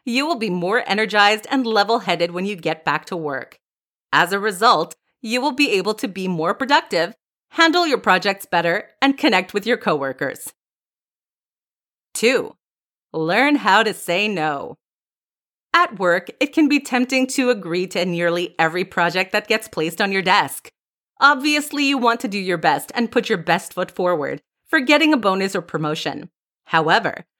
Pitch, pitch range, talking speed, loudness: 205 Hz, 175-265 Hz, 170 wpm, -19 LUFS